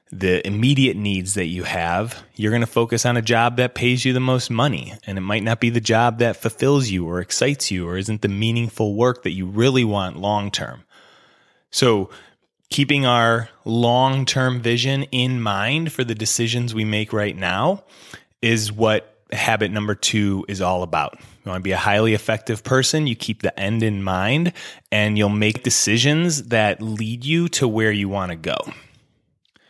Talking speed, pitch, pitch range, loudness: 190 wpm, 110 Hz, 100-125 Hz, -20 LUFS